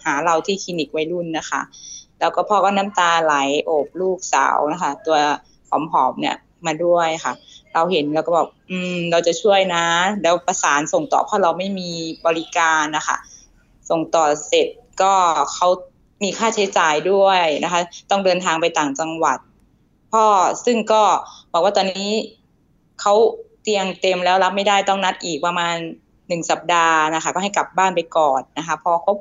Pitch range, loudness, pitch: 160-195 Hz, -18 LUFS, 175 Hz